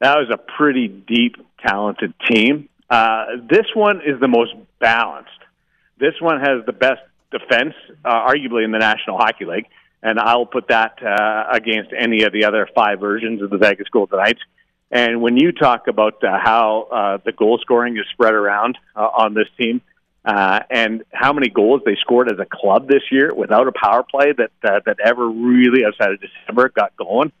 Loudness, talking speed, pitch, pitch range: -16 LUFS, 195 wpm, 115 Hz, 110-130 Hz